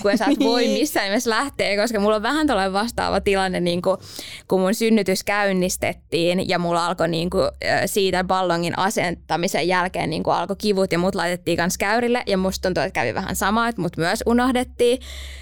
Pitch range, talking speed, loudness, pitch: 180-220 Hz, 185 wpm, -21 LUFS, 195 Hz